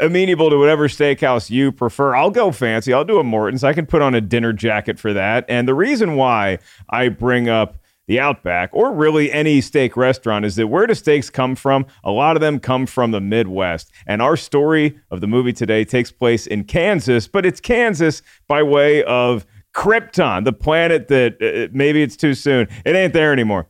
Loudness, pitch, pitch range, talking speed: -16 LUFS, 130 Hz, 115-150 Hz, 205 wpm